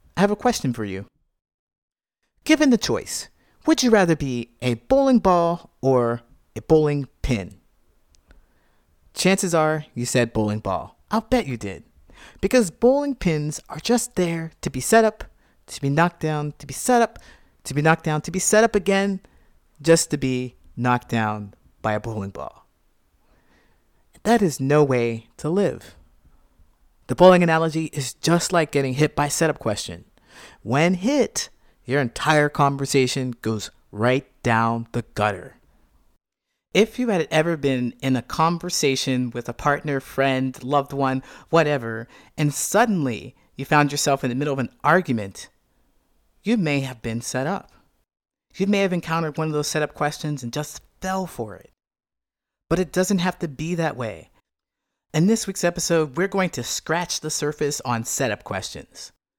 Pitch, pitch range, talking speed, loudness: 150 Hz, 125-175 Hz, 160 wpm, -22 LUFS